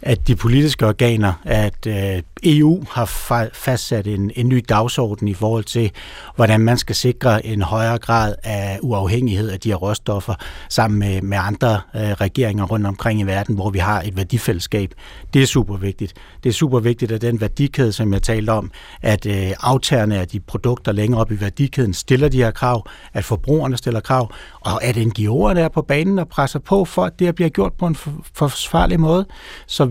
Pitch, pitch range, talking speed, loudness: 115 Hz, 105-130 Hz, 190 wpm, -18 LUFS